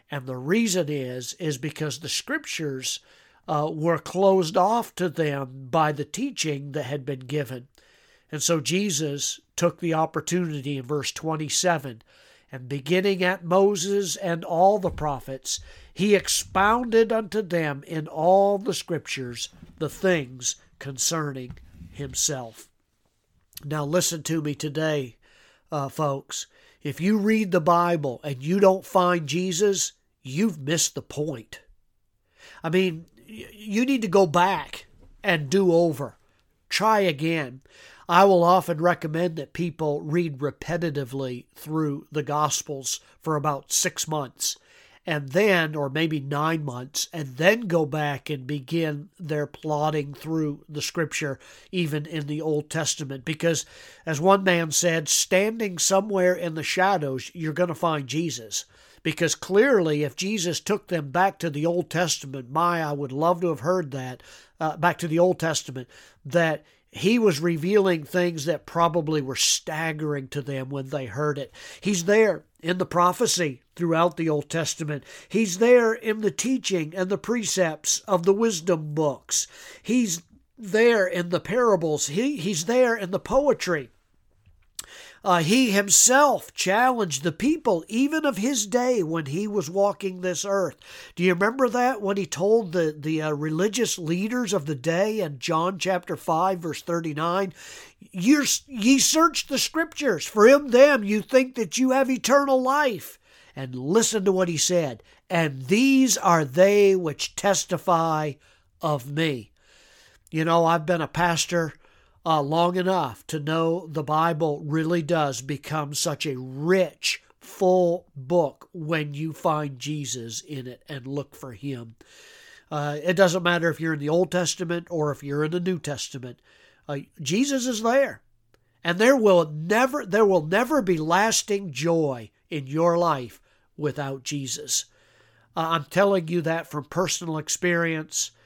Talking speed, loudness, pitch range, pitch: 150 wpm, -24 LUFS, 150-190 Hz, 165 Hz